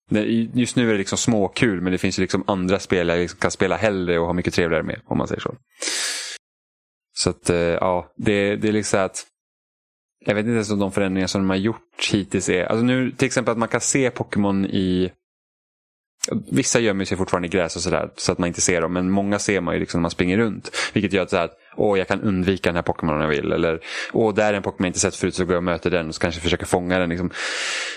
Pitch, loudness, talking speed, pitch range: 95 Hz, -21 LUFS, 260 wpm, 90-105 Hz